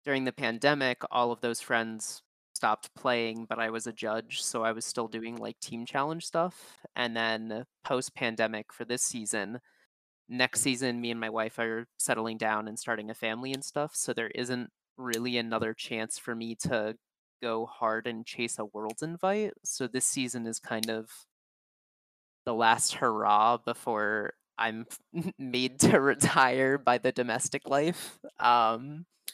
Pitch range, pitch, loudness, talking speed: 115-130 Hz, 120 Hz, -30 LUFS, 165 wpm